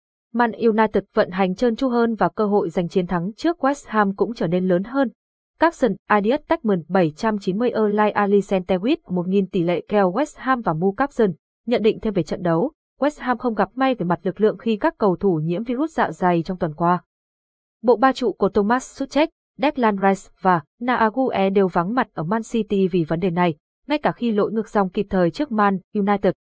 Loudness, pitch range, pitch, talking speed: -21 LUFS, 185-245 Hz, 210 Hz, 210 wpm